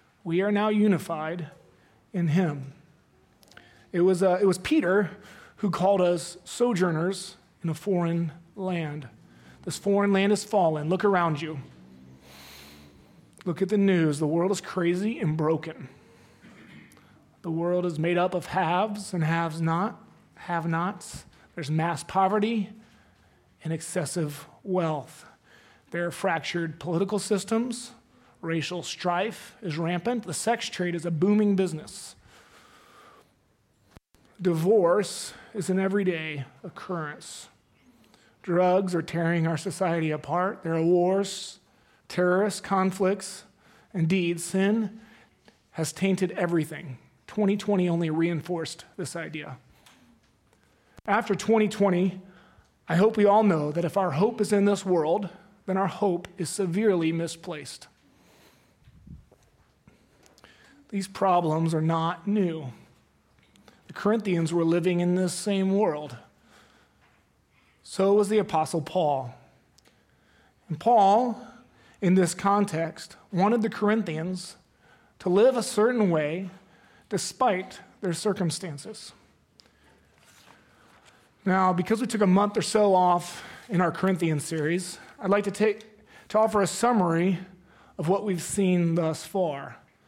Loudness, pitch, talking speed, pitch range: -26 LUFS, 180 Hz, 120 wpm, 165-200 Hz